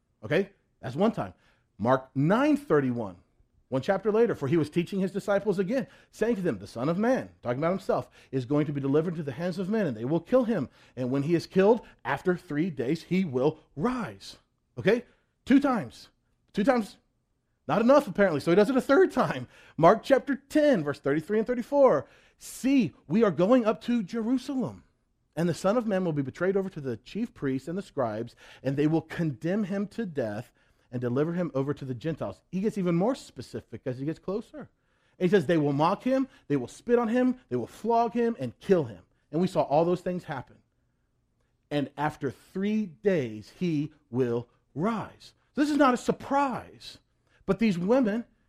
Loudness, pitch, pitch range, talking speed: -27 LUFS, 175 Hz, 140-225 Hz, 200 wpm